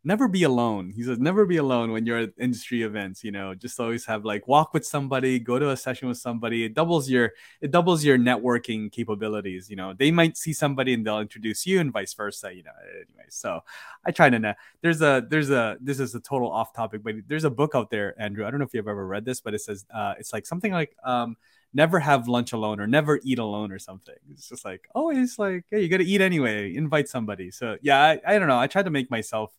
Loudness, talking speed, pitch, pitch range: -24 LUFS, 250 wpm, 125 Hz, 110-150 Hz